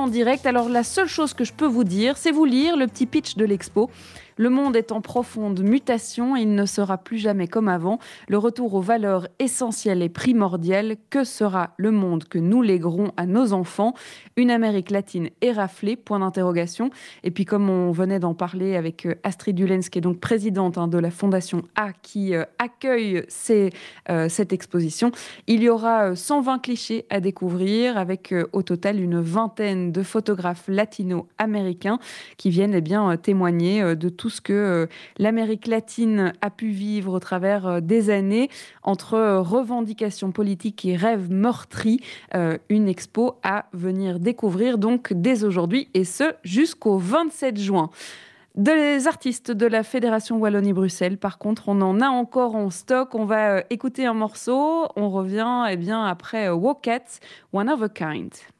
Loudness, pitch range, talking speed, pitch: -22 LUFS, 185-235 Hz, 165 wpm, 210 Hz